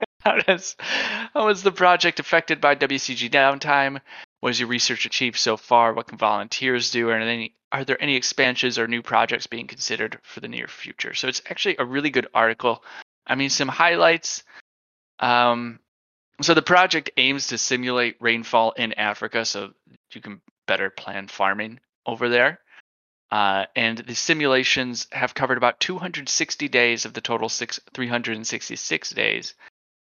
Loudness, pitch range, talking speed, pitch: -21 LUFS, 115-140 Hz, 160 wpm, 120 Hz